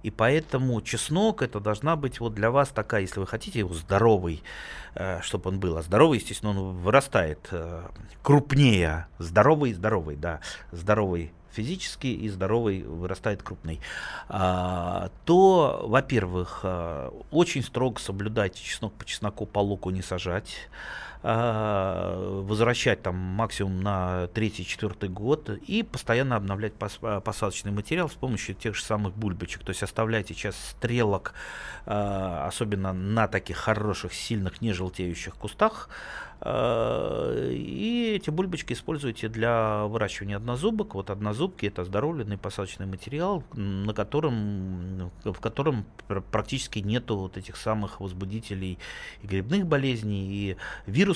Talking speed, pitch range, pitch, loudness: 120 wpm, 95-120 Hz, 105 Hz, -27 LUFS